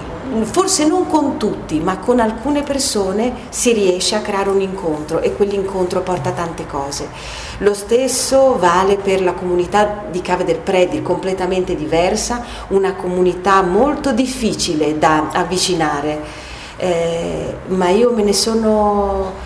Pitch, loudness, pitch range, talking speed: 190 Hz, -16 LUFS, 180-225 Hz, 135 wpm